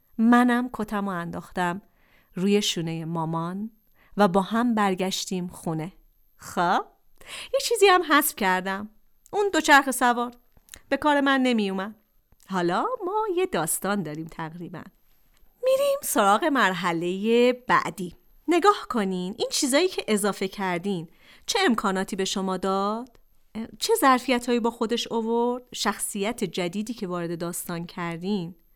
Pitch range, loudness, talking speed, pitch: 185-245 Hz, -24 LUFS, 125 wpm, 205 Hz